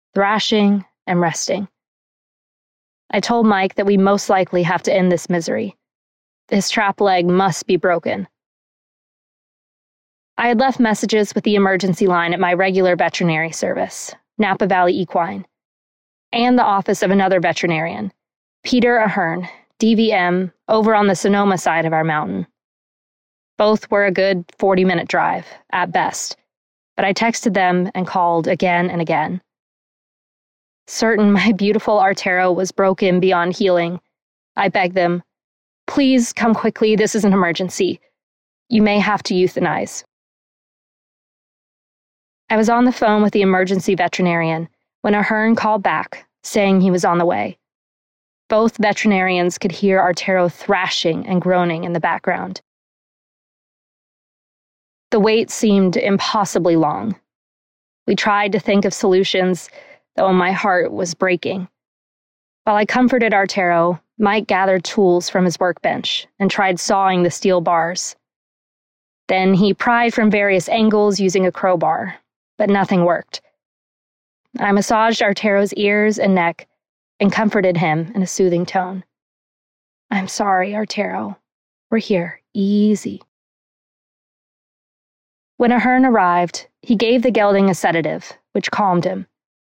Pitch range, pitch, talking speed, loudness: 180-210 Hz, 195 Hz, 135 wpm, -17 LUFS